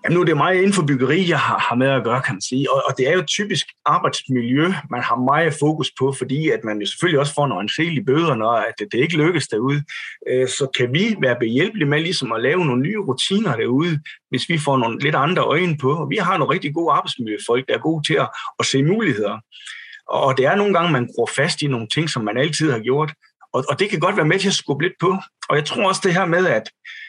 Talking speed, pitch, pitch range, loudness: 250 wpm, 150 Hz, 130-180 Hz, -19 LUFS